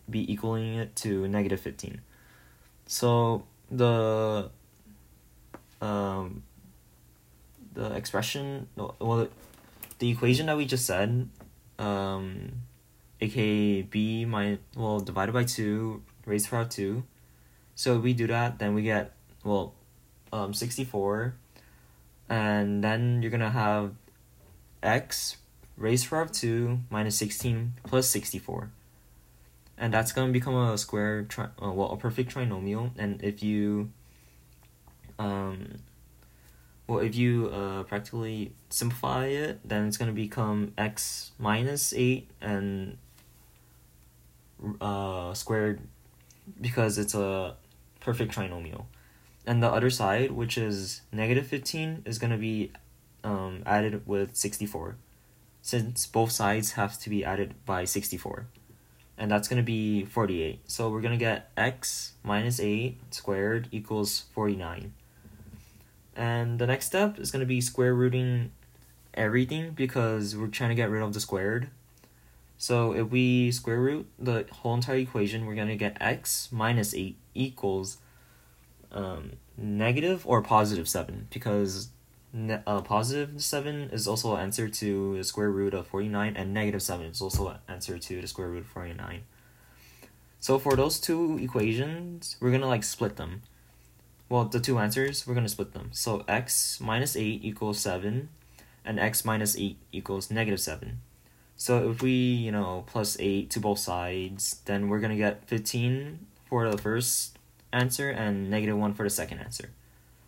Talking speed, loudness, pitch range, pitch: 145 wpm, -29 LUFS, 100-120 Hz, 105 Hz